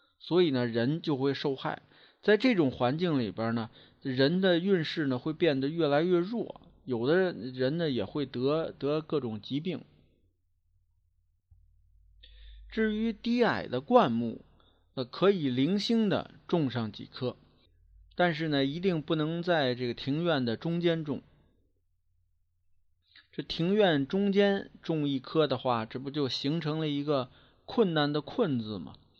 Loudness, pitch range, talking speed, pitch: -30 LUFS, 105-165 Hz, 200 characters per minute, 135 Hz